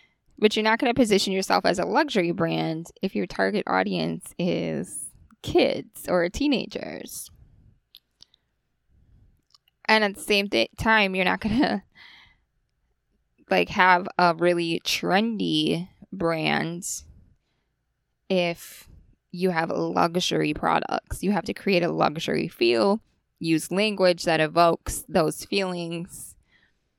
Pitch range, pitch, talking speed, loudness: 170-205 Hz, 180 Hz, 120 wpm, -24 LUFS